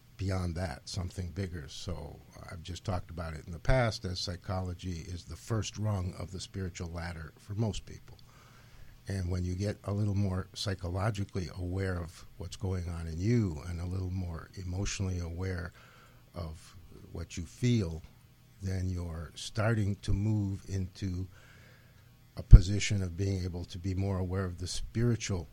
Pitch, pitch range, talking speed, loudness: 95 Hz, 90-105 Hz, 160 wpm, -34 LUFS